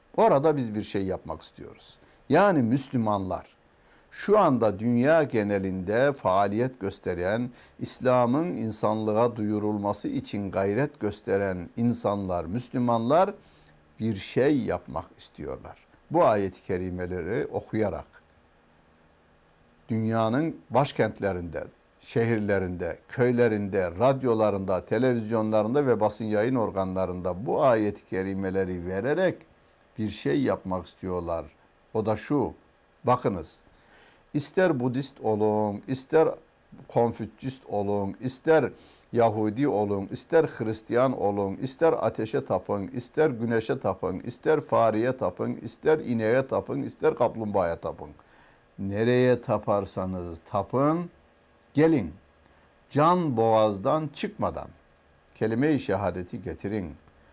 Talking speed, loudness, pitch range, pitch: 95 wpm, -26 LUFS, 95-120 Hz, 105 Hz